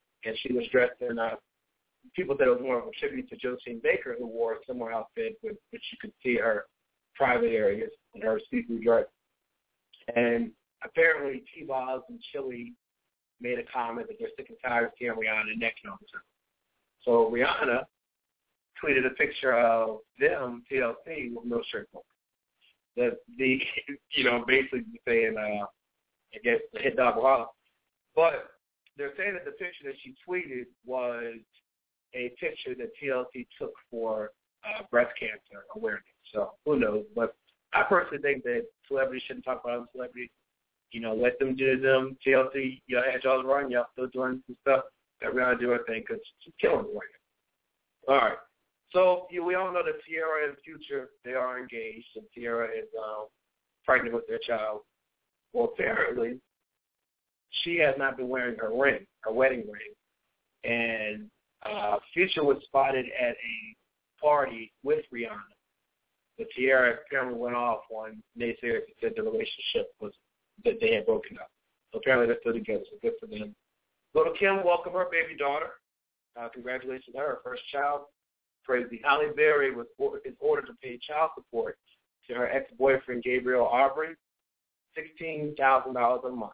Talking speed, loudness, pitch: 170 wpm, -29 LUFS, 135 Hz